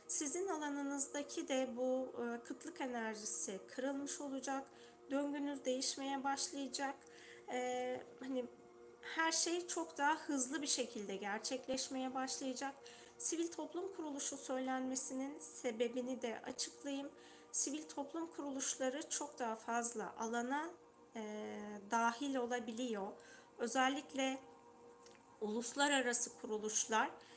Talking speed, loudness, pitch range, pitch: 90 wpm, -40 LUFS, 235-285 Hz, 260 Hz